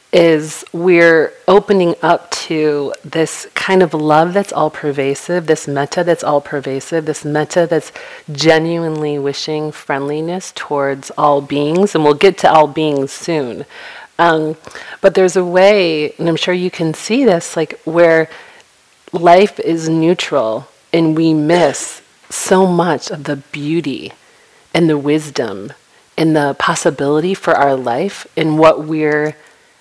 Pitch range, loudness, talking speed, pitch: 150-175 Hz, -14 LUFS, 140 wpm, 160 Hz